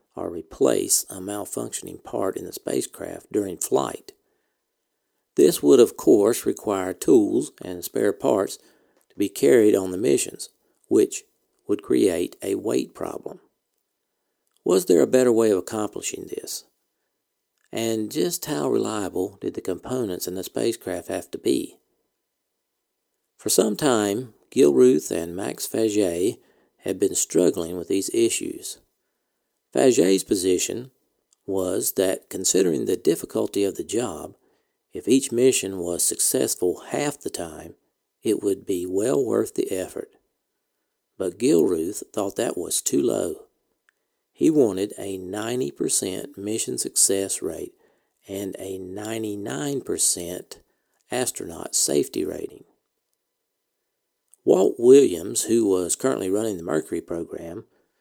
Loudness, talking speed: -23 LUFS, 125 wpm